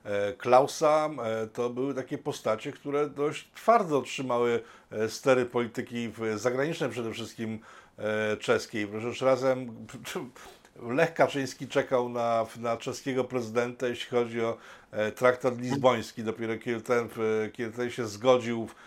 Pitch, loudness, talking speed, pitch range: 120 Hz, -29 LUFS, 120 wpm, 115-130 Hz